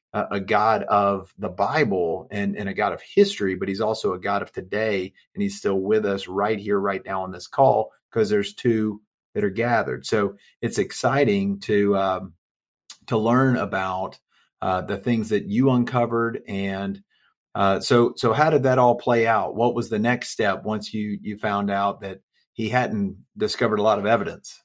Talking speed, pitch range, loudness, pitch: 190 wpm, 100-120 Hz, -23 LUFS, 105 Hz